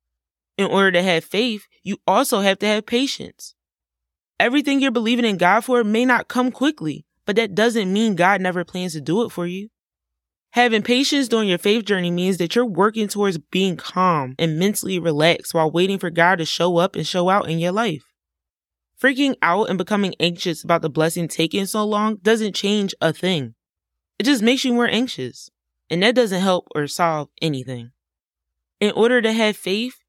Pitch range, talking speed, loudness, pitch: 165-225 Hz, 190 wpm, -19 LUFS, 190 Hz